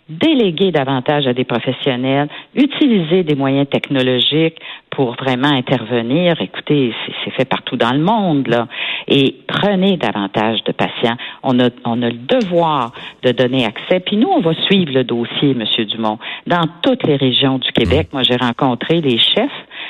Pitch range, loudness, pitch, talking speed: 120-165 Hz, -15 LUFS, 135 Hz, 165 wpm